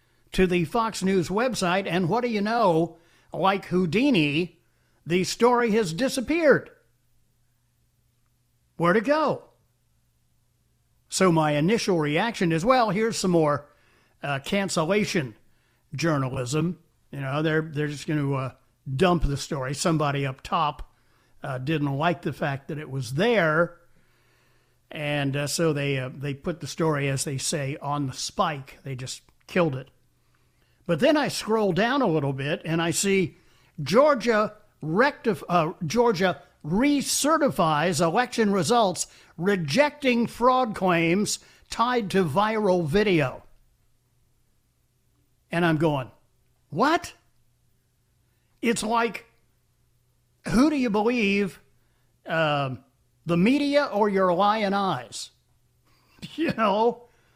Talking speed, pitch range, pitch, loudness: 120 wpm, 130-205 Hz, 165 Hz, -24 LUFS